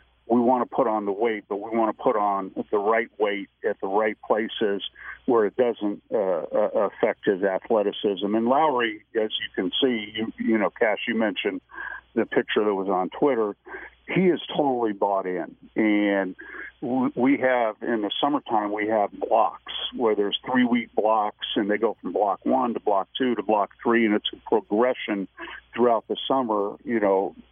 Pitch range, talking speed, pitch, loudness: 100-120 Hz, 185 wpm, 110 Hz, -24 LUFS